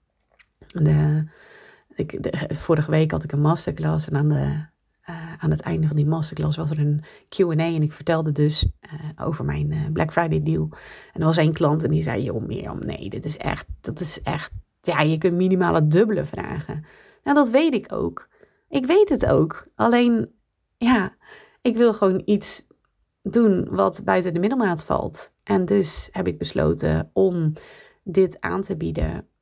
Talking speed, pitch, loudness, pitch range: 180 wpm, 160 Hz, -22 LUFS, 150-190 Hz